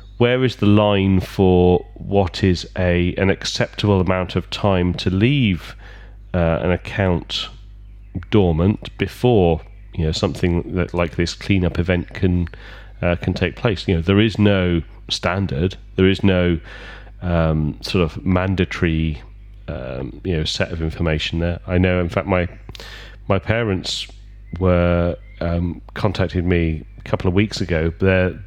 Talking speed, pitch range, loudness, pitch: 150 wpm, 85-100 Hz, -19 LUFS, 95 Hz